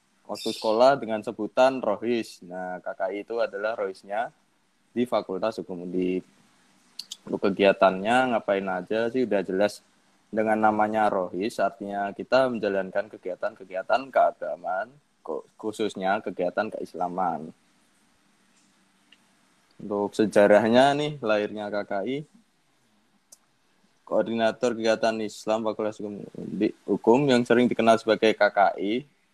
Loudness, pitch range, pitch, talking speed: -25 LUFS, 100-115 Hz, 110 Hz, 100 wpm